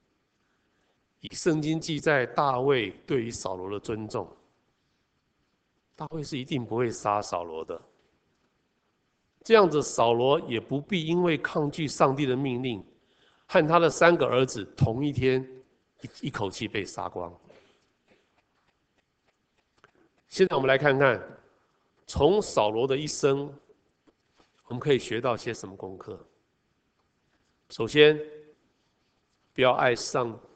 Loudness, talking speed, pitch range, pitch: -26 LUFS, 175 characters per minute, 125-155 Hz, 140 Hz